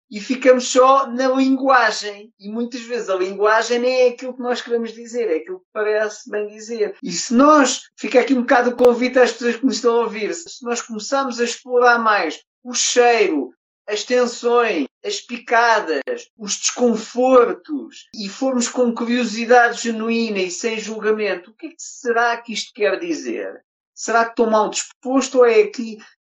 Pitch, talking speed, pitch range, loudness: 240 Hz, 180 wpm, 225-260 Hz, -18 LUFS